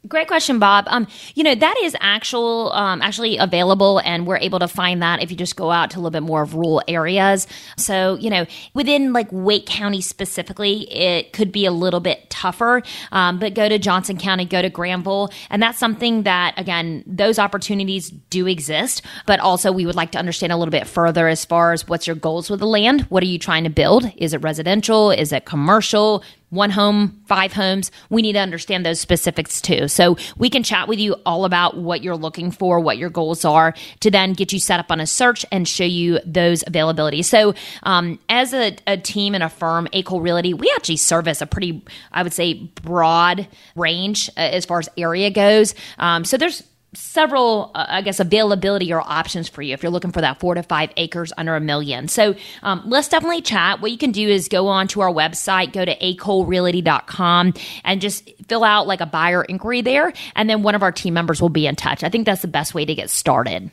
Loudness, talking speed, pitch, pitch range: -18 LUFS, 220 wpm, 185 Hz, 170-205 Hz